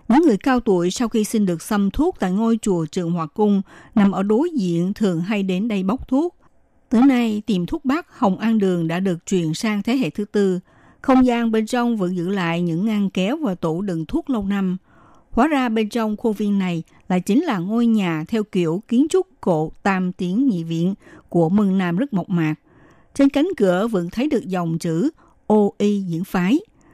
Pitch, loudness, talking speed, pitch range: 200 Hz, -20 LUFS, 215 wpm, 180-235 Hz